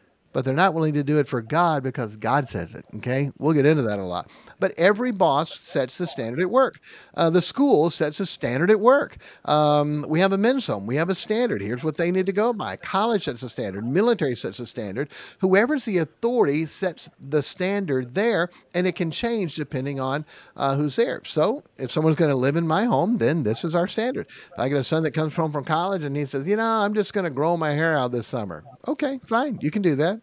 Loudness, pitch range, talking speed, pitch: -23 LUFS, 140-195 Hz, 240 wpm, 160 Hz